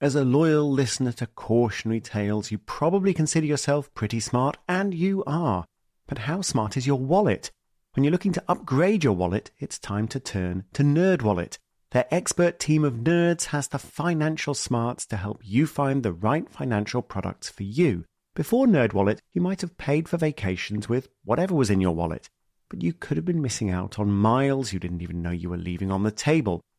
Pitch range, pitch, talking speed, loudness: 105-155 Hz, 130 Hz, 195 wpm, -25 LUFS